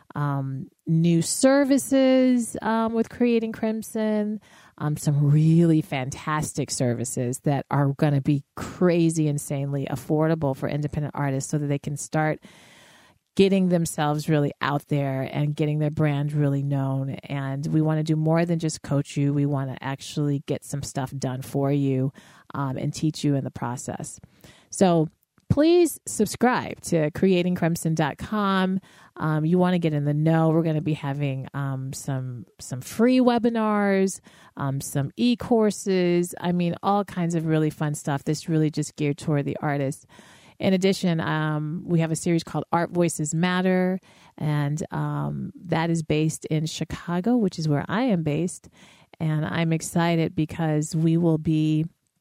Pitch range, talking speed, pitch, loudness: 145-175 Hz, 155 wpm, 155 Hz, -24 LUFS